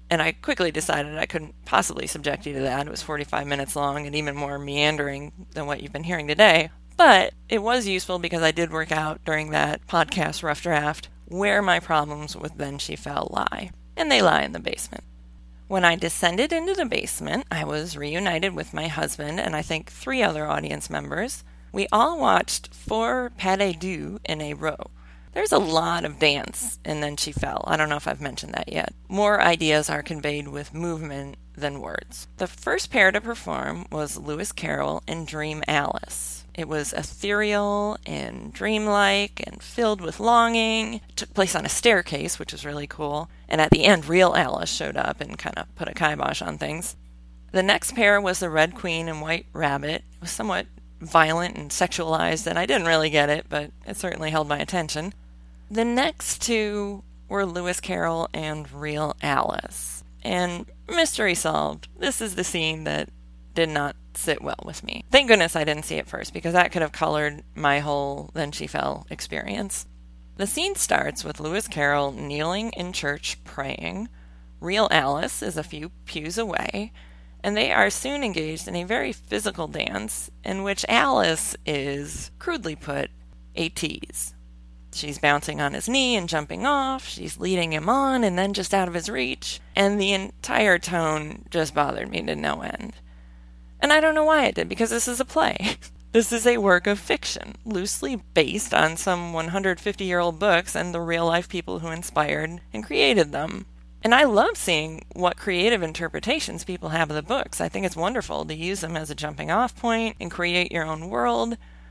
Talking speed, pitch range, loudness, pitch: 190 wpm, 145-195 Hz, -24 LUFS, 160 Hz